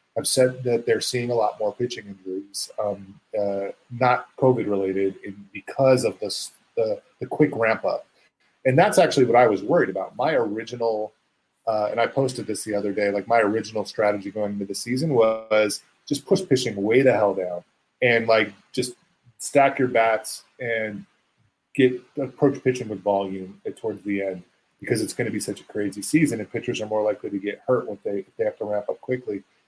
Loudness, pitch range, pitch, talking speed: -23 LUFS, 100-125 Hz, 110 Hz, 200 wpm